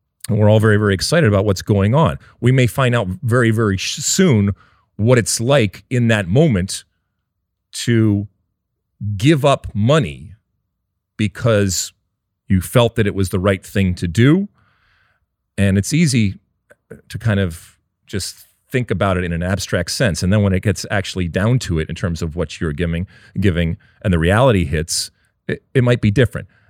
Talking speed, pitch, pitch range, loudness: 175 wpm, 100 Hz, 95-115 Hz, -17 LUFS